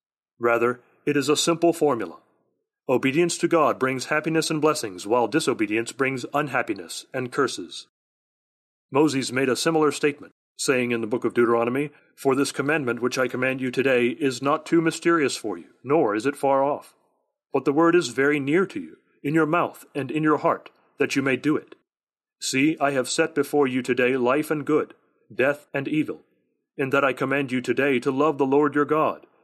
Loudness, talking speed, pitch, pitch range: -23 LUFS, 190 wpm, 145 Hz, 130-155 Hz